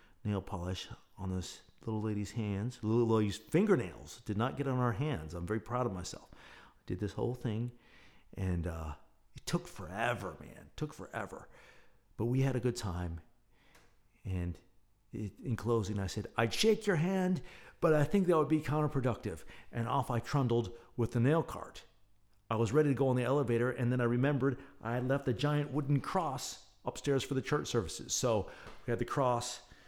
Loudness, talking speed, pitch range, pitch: -34 LUFS, 190 wpm, 100-135 Hz, 120 Hz